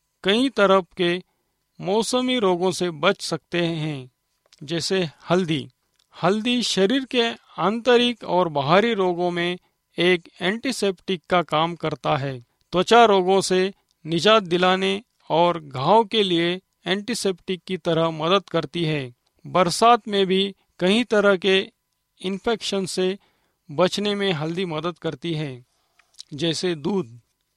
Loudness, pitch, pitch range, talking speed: -22 LUFS, 185 Hz, 165-200 Hz, 120 wpm